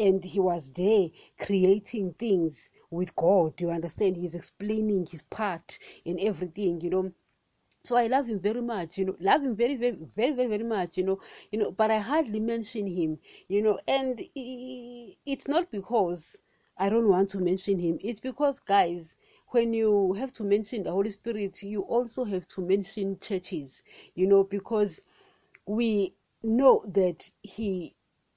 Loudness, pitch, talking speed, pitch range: -28 LUFS, 205 Hz, 165 wpm, 185-230 Hz